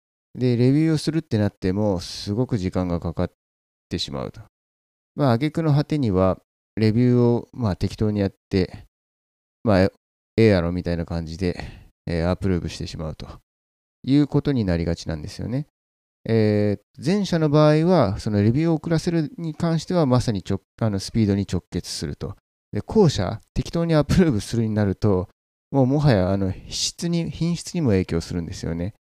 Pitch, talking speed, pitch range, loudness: 105 Hz, 355 characters per minute, 85-140 Hz, -22 LUFS